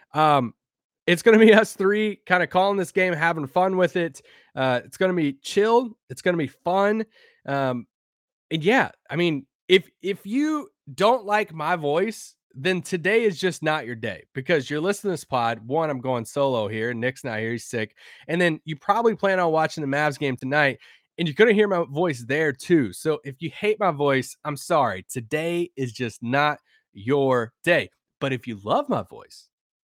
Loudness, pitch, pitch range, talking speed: -23 LUFS, 155 Hz, 135-185 Hz, 205 wpm